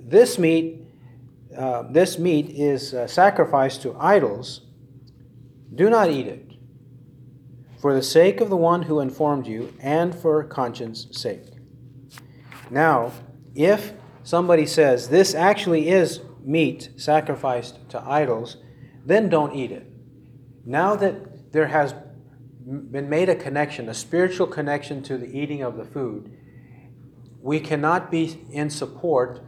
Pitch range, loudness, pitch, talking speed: 125-160 Hz, -21 LUFS, 135 Hz, 130 wpm